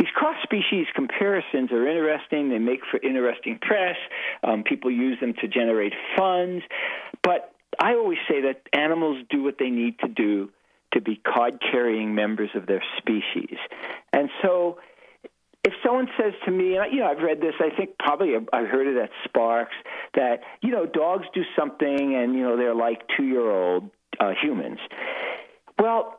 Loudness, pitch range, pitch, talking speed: -24 LUFS, 120-200 Hz, 145 Hz, 165 wpm